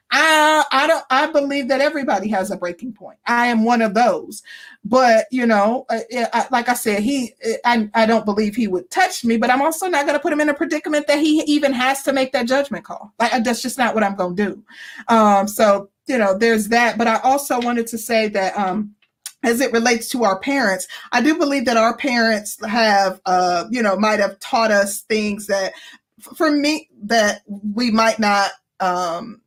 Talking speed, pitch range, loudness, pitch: 220 wpm, 210-265 Hz, -18 LUFS, 235 Hz